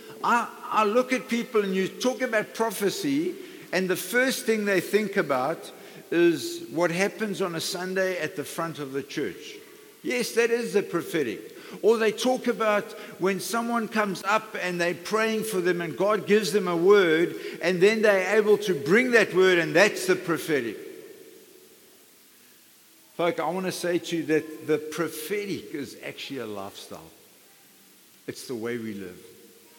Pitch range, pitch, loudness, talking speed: 180-250 Hz, 210 Hz, -25 LUFS, 165 wpm